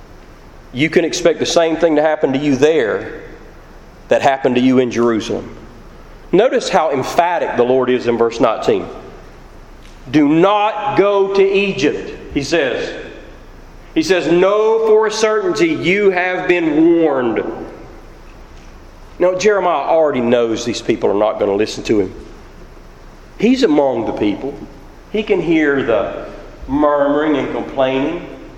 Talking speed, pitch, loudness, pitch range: 140 wpm, 165 Hz, -15 LUFS, 135-200 Hz